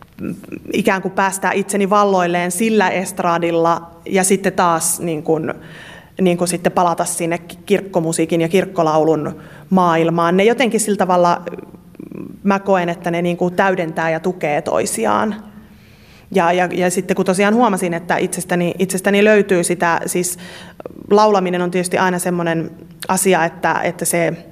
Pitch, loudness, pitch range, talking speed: 180 Hz, -16 LUFS, 170-195 Hz, 140 wpm